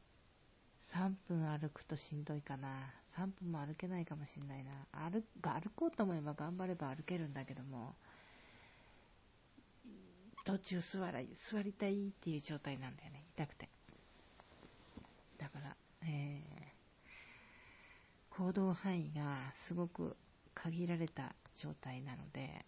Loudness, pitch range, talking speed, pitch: -45 LUFS, 140-185 Hz, 235 characters per minute, 155 Hz